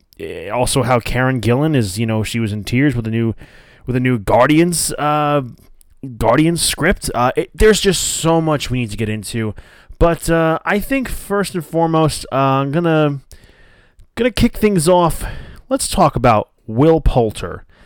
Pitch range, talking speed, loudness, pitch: 115-165 Hz, 170 wpm, -16 LUFS, 135 Hz